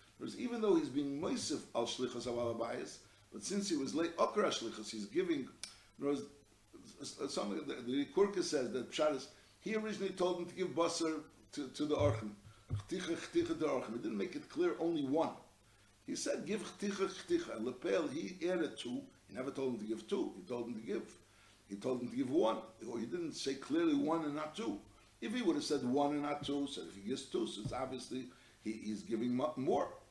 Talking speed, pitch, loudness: 190 wpm, 150 Hz, -39 LUFS